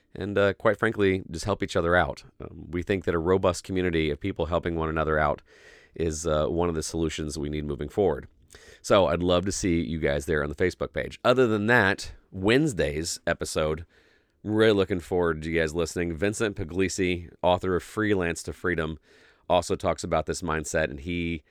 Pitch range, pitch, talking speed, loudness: 80-95 Hz, 85 Hz, 200 wpm, -26 LUFS